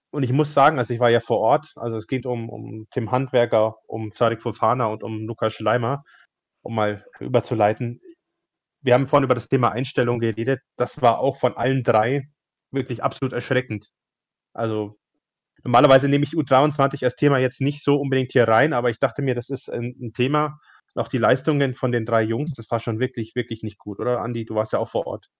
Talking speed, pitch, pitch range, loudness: 205 wpm, 125 Hz, 115-135 Hz, -22 LUFS